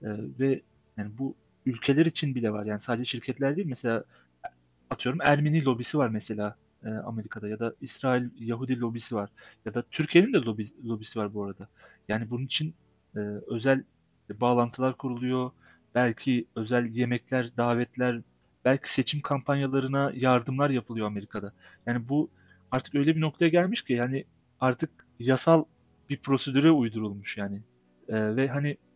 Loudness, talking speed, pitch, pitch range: -28 LUFS, 135 wpm, 125 Hz, 110-135 Hz